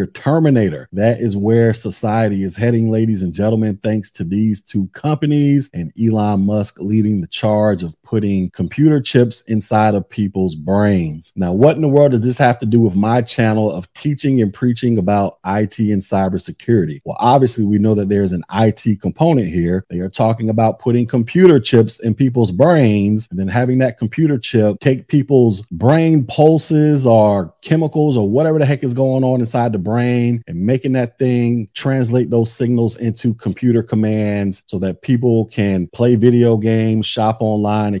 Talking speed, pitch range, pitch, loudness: 175 wpm, 105-125 Hz, 115 Hz, -15 LUFS